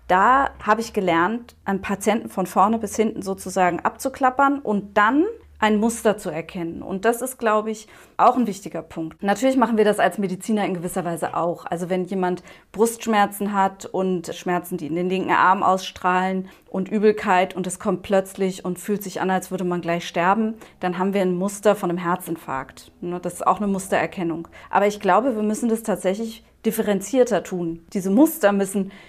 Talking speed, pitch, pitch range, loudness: 185 wpm, 195 Hz, 180-215 Hz, -22 LUFS